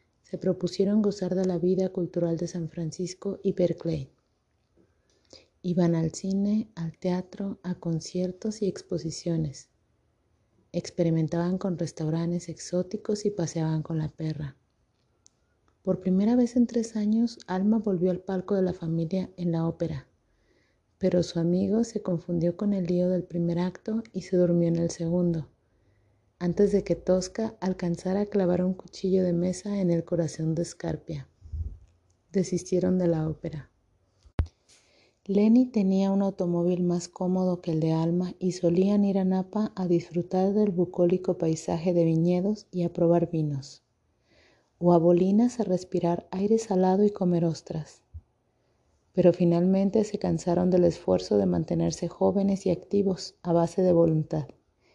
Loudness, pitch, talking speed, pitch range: -27 LUFS, 175 Hz, 145 wpm, 165-190 Hz